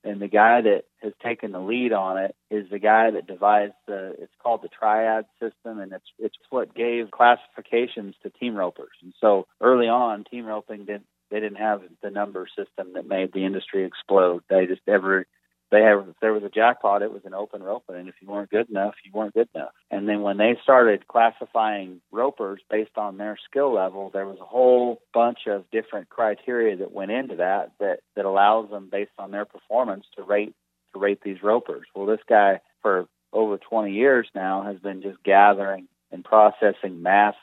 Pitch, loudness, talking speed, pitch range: 105 Hz, -22 LUFS, 200 wpm, 95-110 Hz